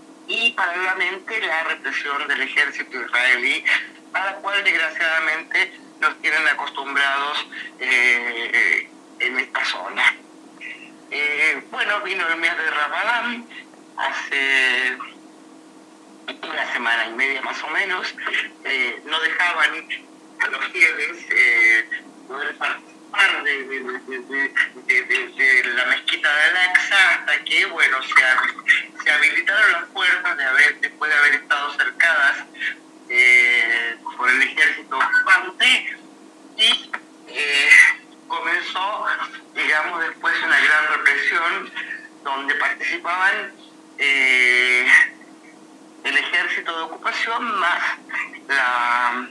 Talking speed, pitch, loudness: 105 wpm, 315 Hz, -18 LUFS